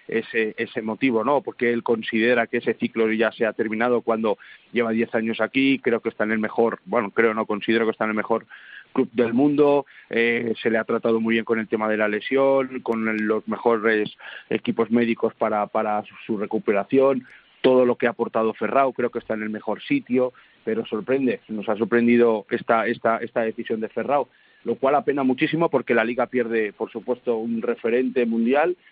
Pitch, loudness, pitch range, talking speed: 115 Hz, -22 LUFS, 110-120 Hz, 200 wpm